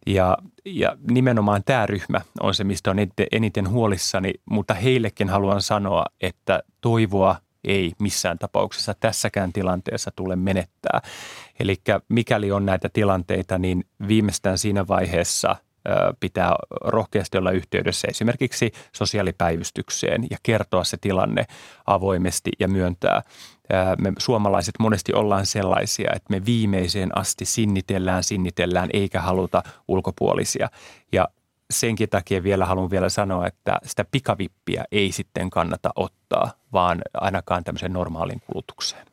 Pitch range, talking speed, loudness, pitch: 95-110 Hz, 120 wpm, -23 LUFS, 100 Hz